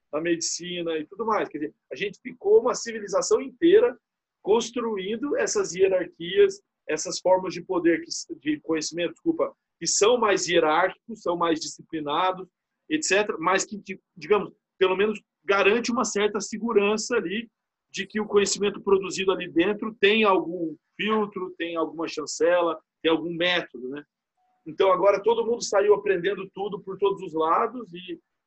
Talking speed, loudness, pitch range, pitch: 150 wpm, -24 LUFS, 175-230 Hz, 200 Hz